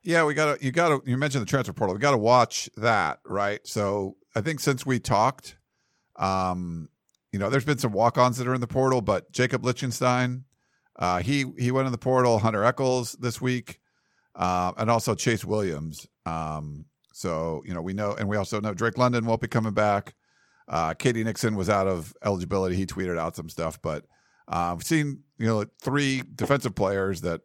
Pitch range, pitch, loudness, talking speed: 95-130 Hz, 115 Hz, -26 LUFS, 205 wpm